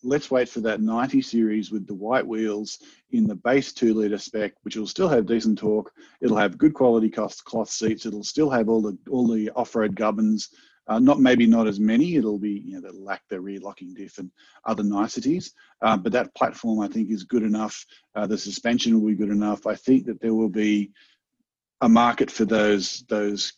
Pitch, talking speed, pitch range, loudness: 110 Hz, 210 wpm, 105-120 Hz, -23 LUFS